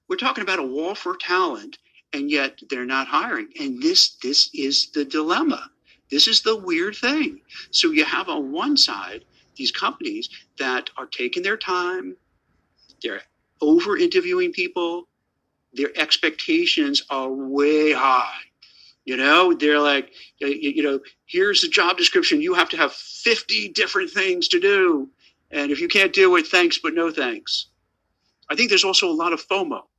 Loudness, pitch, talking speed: -20 LUFS, 270 Hz, 160 wpm